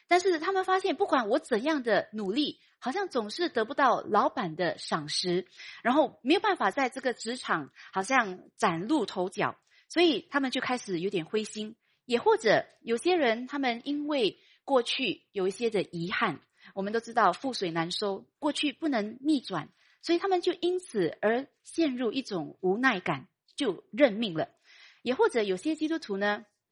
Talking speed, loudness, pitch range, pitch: 260 characters per minute, -29 LUFS, 205-320 Hz, 255 Hz